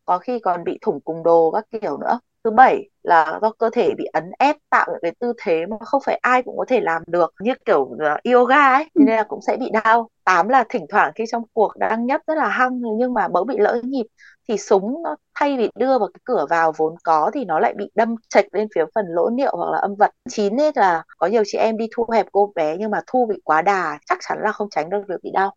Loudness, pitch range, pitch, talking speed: -19 LUFS, 190-250 Hz, 220 Hz, 270 wpm